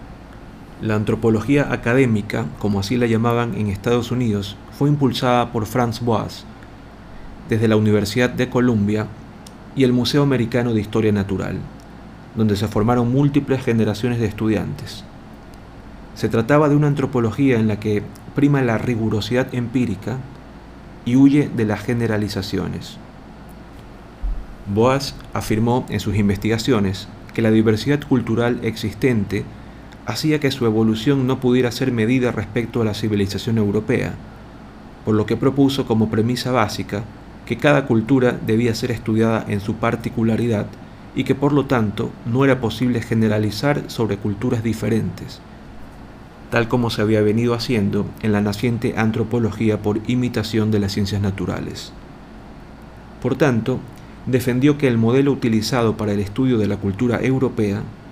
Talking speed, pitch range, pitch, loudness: 135 wpm, 105-125 Hz, 115 Hz, -19 LUFS